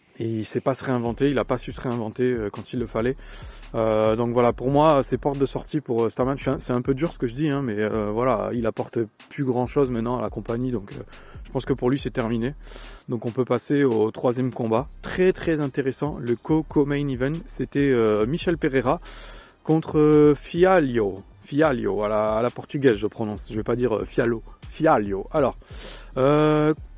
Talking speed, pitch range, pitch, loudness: 220 wpm, 115-145 Hz, 130 Hz, -23 LUFS